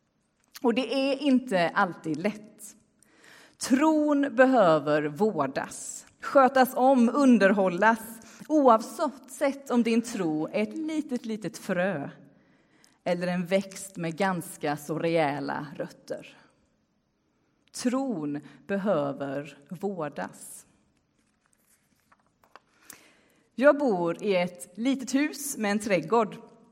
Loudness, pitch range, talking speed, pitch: -26 LUFS, 180-255 Hz, 90 wpm, 215 Hz